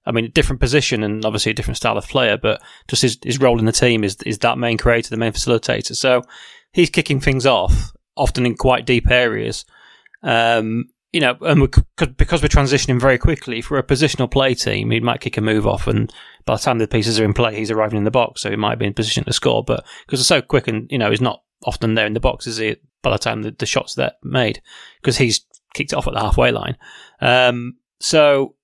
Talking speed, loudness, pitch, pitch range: 245 wpm, -18 LUFS, 120 Hz, 110-130 Hz